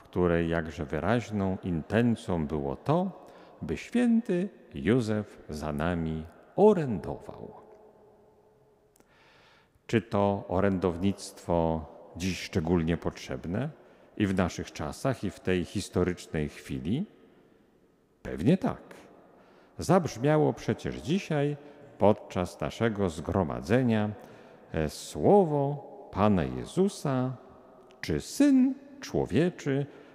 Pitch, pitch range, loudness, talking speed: 100 Hz, 85-140 Hz, -29 LUFS, 80 wpm